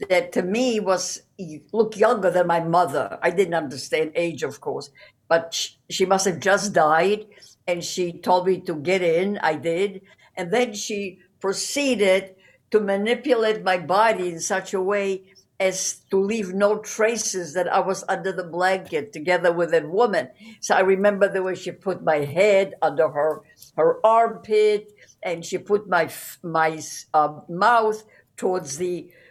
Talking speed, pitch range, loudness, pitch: 165 wpm, 175-205 Hz, -22 LUFS, 190 Hz